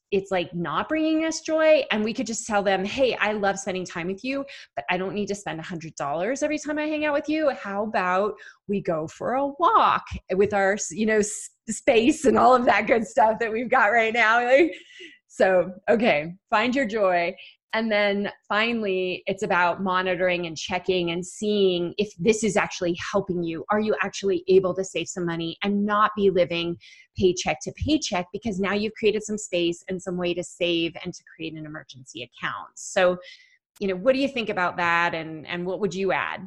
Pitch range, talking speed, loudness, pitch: 180-225 Hz, 205 wpm, -24 LUFS, 195 Hz